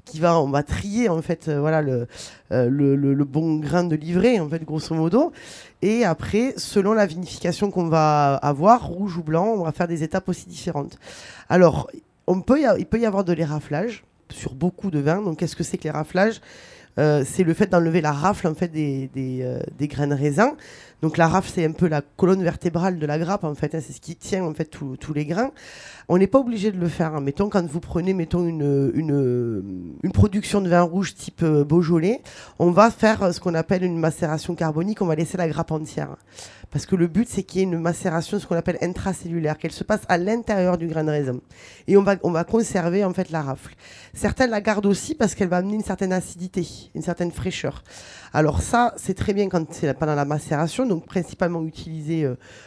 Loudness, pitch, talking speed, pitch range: -22 LUFS, 170 Hz, 225 wpm, 150-190 Hz